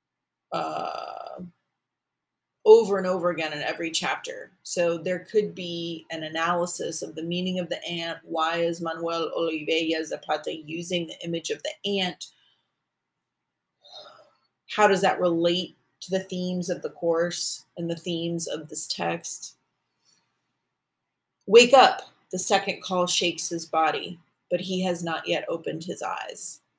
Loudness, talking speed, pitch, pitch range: -25 LUFS, 140 wpm, 175 Hz, 165-185 Hz